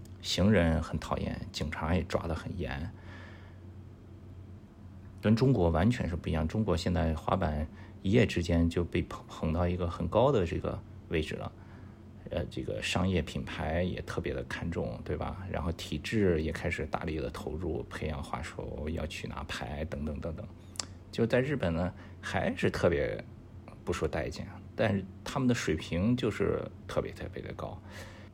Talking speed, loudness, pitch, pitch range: 235 characters per minute, -32 LUFS, 95 Hz, 85-105 Hz